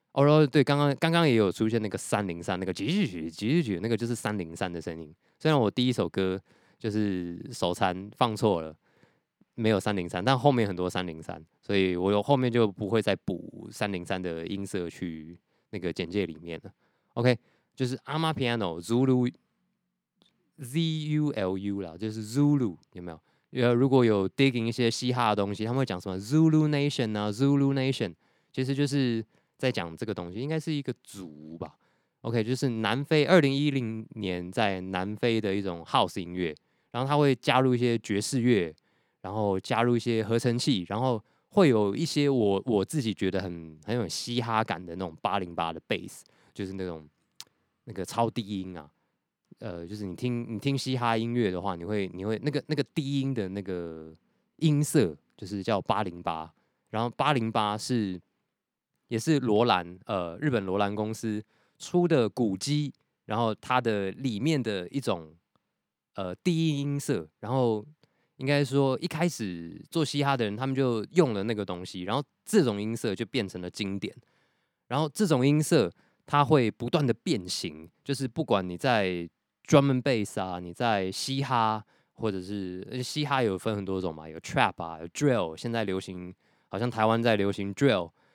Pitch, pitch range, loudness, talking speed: 110 Hz, 95-135 Hz, -28 LUFS, 295 characters per minute